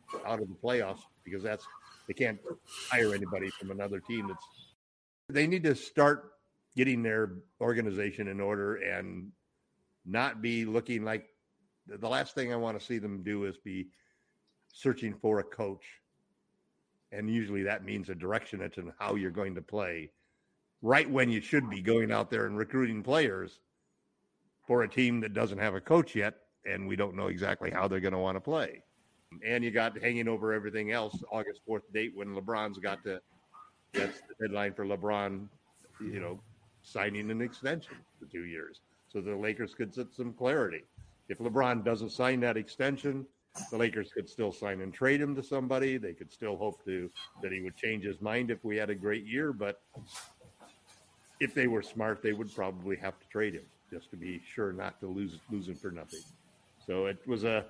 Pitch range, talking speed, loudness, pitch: 100-120 Hz, 190 wpm, -33 LUFS, 110 Hz